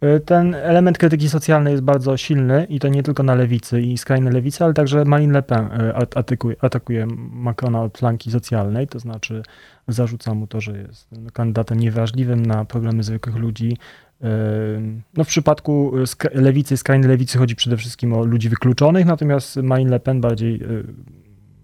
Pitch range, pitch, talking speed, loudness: 115-140 Hz, 125 Hz, 160 wpm, -18 LUFS